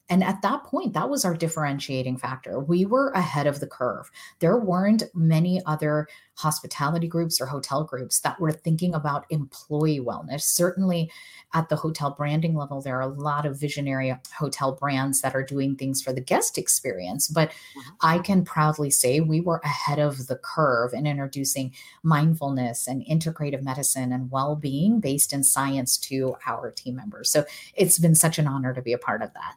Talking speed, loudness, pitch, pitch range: 185 wpm, -24 LUFS, 150 Hz, 135-165 Hz